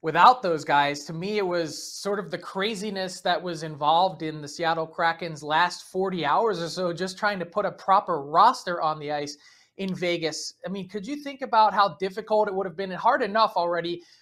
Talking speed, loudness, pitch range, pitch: 215 wpm, -25 LUFS, 165-200 Hz, 180 Hz